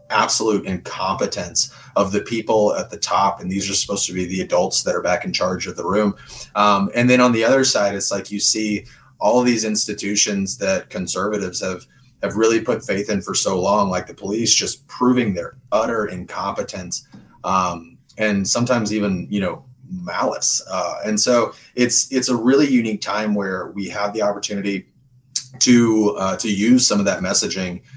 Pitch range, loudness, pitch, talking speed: 100-125 Hz, -19 LUFS, 105 Hz, 185 wpm